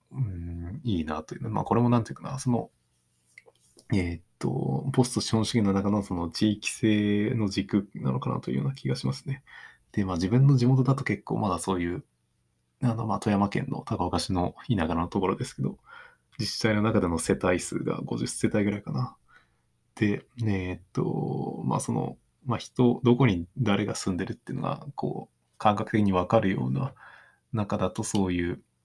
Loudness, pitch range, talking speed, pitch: -28 LUFS, 90-115 Hz, 340 characters per minute, 105 Hz